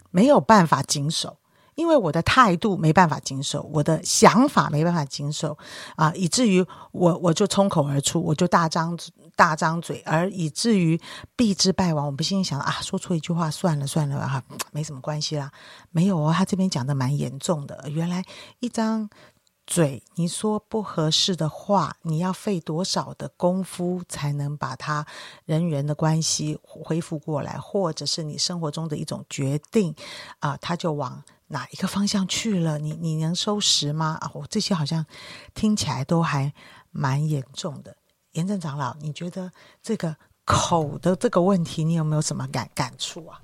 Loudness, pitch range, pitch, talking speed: -23 LUFS, 150-190 Hz, 165 Hz, 265 characters per minute